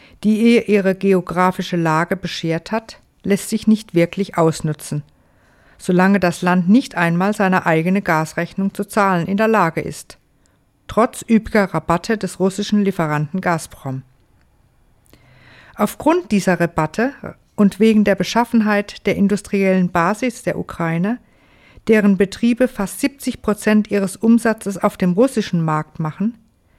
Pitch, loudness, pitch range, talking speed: 195 Hz, -17 LUFS, 170-215 Hz, 130 wpm